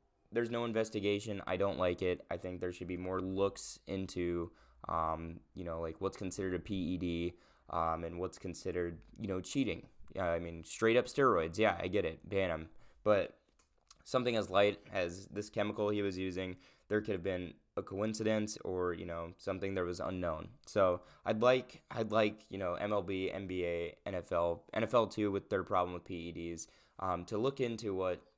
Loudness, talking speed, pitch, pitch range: -37 LUFS, 180 wpm, 95 Hz, 85-105 Hz